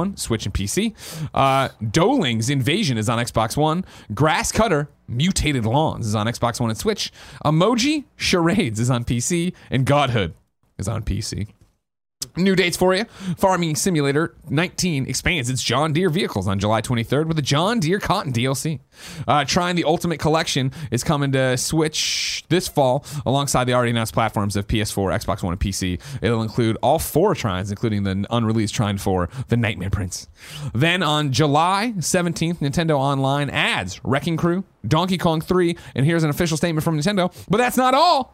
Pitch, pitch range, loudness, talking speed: 140 Hz, 115-170 Hz, -20 LUFS, 170 wpm